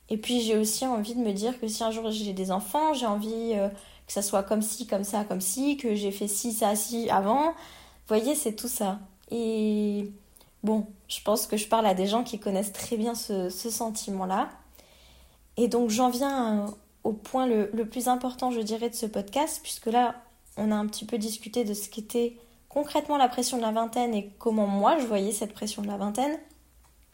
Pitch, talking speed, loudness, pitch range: 225 Hz, 220 wpm, -28 LUFS, 210-240 Hz